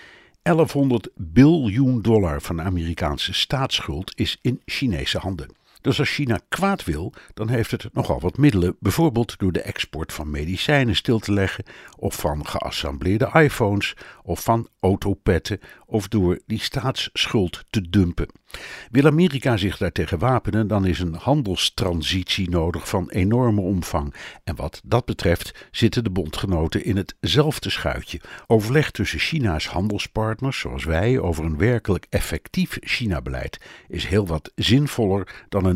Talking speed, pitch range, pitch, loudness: 140 wpm, 85-120 Hz, 100 Hz, -22 LUFS